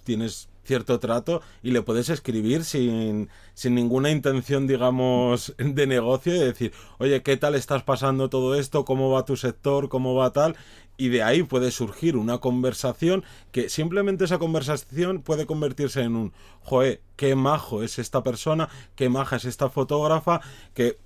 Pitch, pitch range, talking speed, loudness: 130 Hz, 120-145 Hz, 160 wpm, -24 LUFS